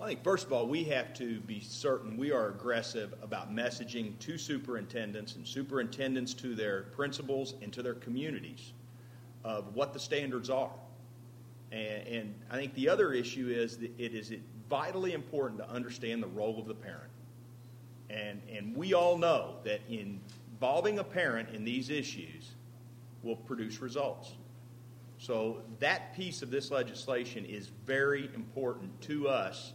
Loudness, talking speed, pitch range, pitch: -36 LUFS, 155 wpm, 115-135 Hz, 120 Hz